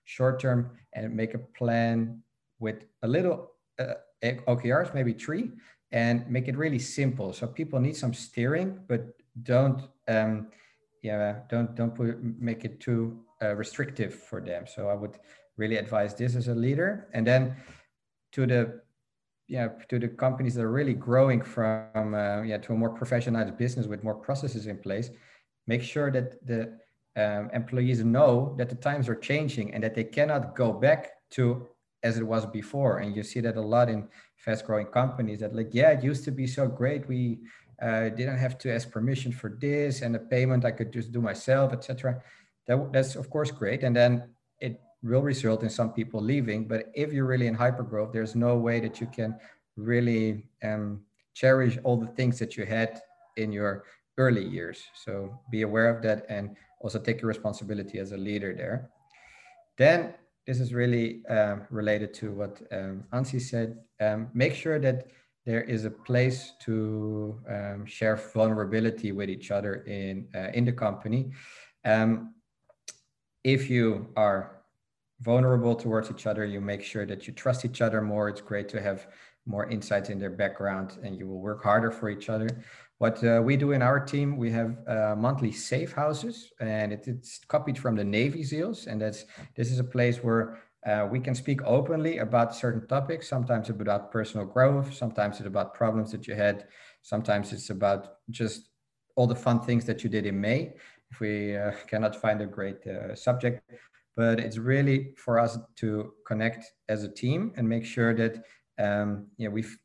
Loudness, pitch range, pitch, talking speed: -29 LUFS, 110-125 Hz, 115 Hz, 185 wpm